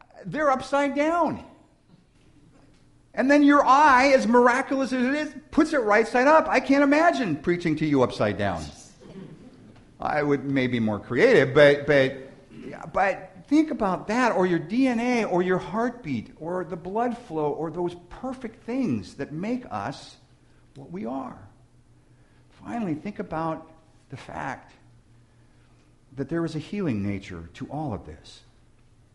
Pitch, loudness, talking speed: 180 Hz, -23 LUFS, 145 wpm